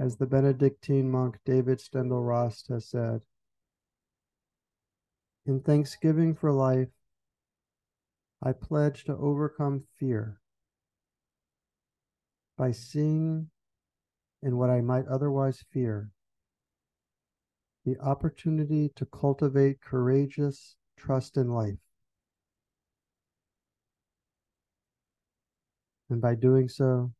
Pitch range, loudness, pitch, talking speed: 115-140 Hz, -28 LUFS, 130 Hz, 85 wpm